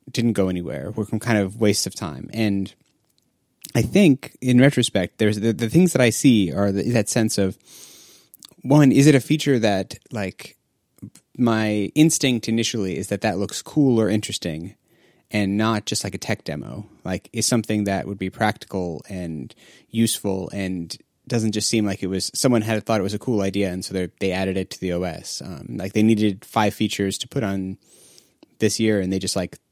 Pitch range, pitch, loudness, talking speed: 95-115 Hz, 105 Hz, -21 LUFS, 200 wpm